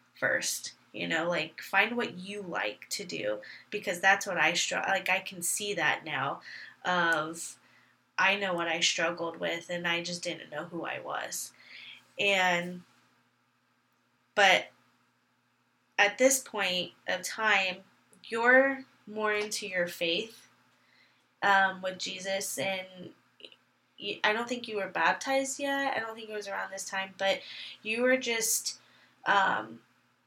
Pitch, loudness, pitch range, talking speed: 195 Hz, -29 LUFS, 175-215 Hz, 145 wpm